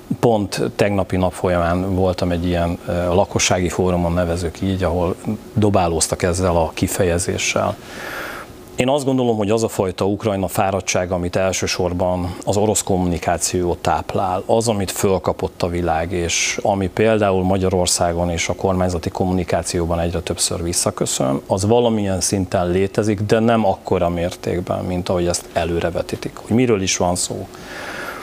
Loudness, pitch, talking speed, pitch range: -19 LUFS, 90 Hz, 135 wpm, 85-100 Hz